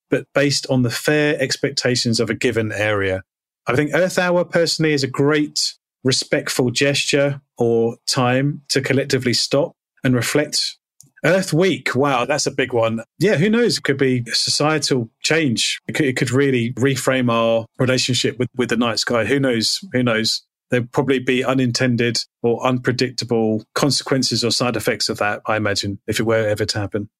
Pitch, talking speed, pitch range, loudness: 130 Hz, 175 wpm, 115-140 Hz, -18 LUFS